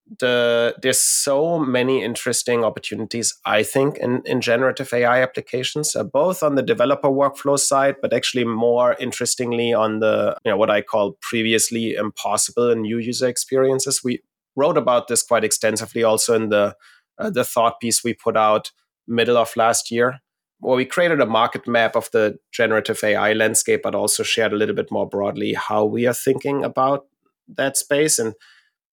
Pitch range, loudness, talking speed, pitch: 115-130 Hz, -19 LUFS, 175 wpm, 120 Hz